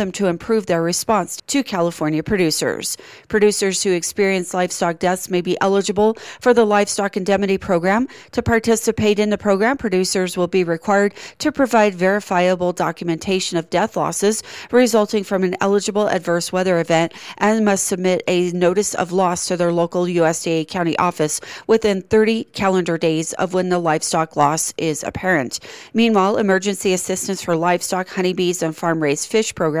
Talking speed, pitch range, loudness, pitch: 155 wpm, 175-210 Hz, -18 LUFS, 185 Hz